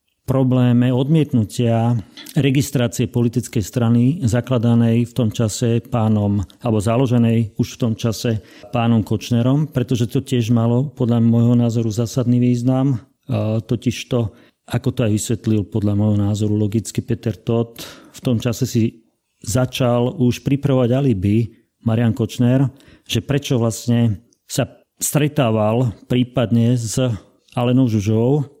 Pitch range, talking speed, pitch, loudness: 115-125 Hz, 120 wpm, 120 Hz, -18 LUFS